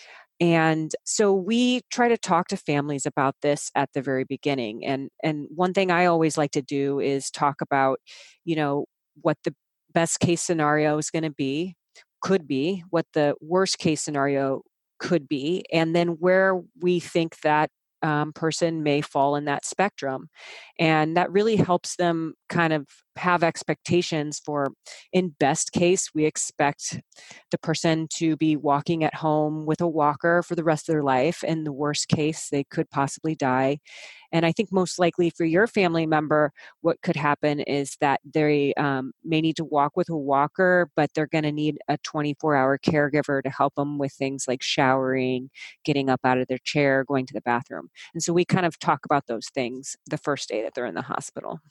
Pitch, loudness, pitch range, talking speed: 155 Hz, -24 LUFS, 140-170 Hz, 190 wpm